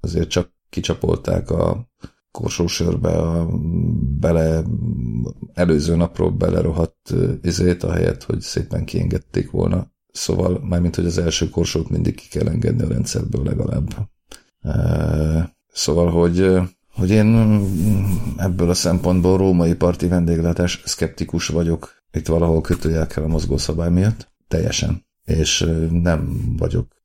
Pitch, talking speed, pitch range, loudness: 85 Hz, 120 wpm, 80-90 Hz, -20 LUFS